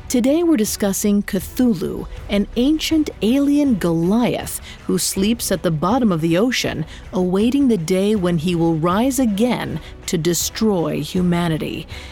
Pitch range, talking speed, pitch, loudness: 180-245 Hz, 135 wpm, 205 Hz, -19 LUFS